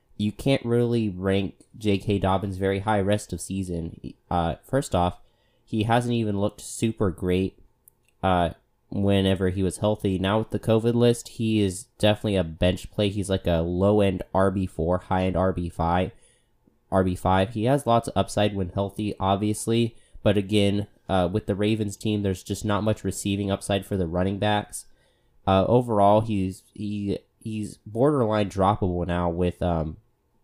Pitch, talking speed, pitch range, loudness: 100 Hz, 165 wpm, 95-110 Hz, -25 LUFS